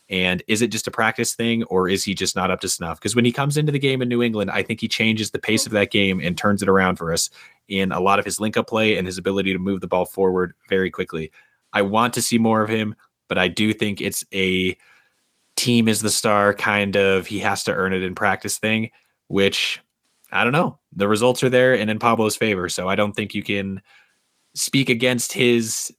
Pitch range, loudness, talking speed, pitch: 95-115 Hz, -20 LUFS, 245 wpm, 105 Hz